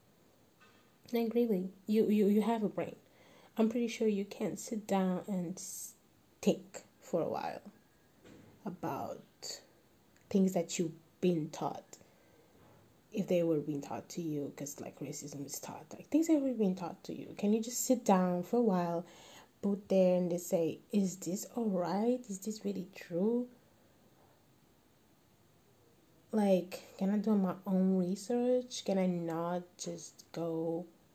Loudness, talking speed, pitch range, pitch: -35 LUFS, 150 wpm, 170-215 Hz, 185 Hz